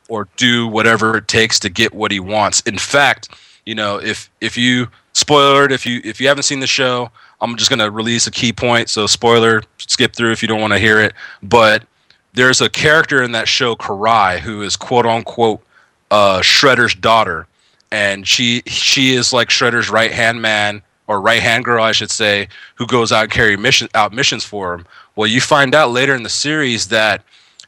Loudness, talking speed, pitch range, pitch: -13 LUFS, 205 wpm, 110-125 Hz, 115 Hz